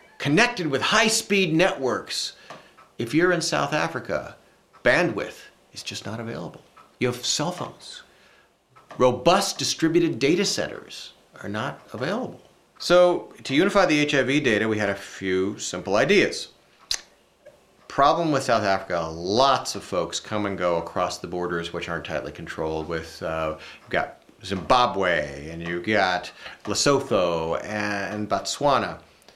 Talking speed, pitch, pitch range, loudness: 135 wpm, 100 Hz, 85-140 Hz, -23 LUFS